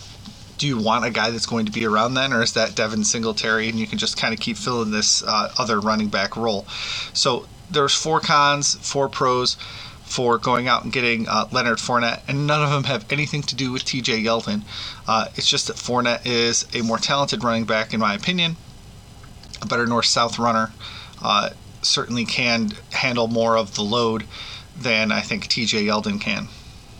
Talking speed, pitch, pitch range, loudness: 195 wpm, 115 Hz, 110-125 Hz, -20 LUFS